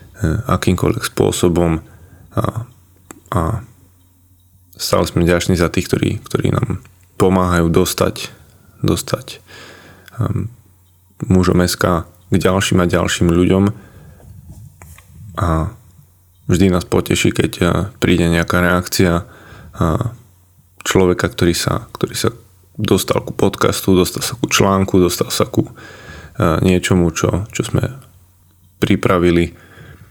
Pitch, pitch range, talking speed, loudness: 90 Hz, 90-100 Hz, 110 wpm, -16 LUFS